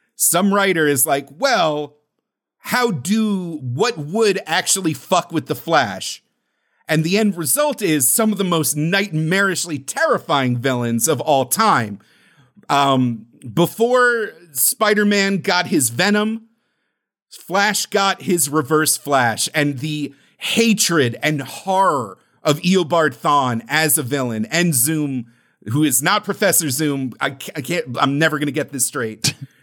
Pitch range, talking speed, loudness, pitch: 140-195 Hz, 135 wpm, -18 LUFS, 155 Hz